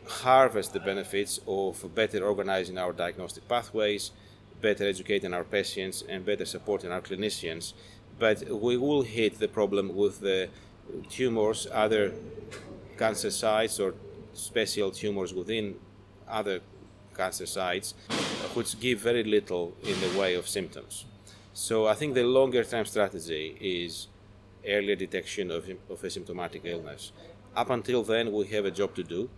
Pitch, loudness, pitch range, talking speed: 100 Hz, -29 LUFS, 95-110 Hz, 140 wpm